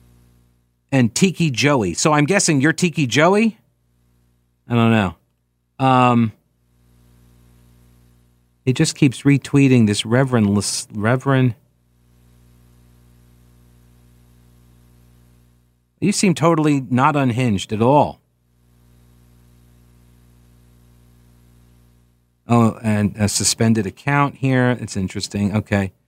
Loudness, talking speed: -17 LUFS, 80 wpm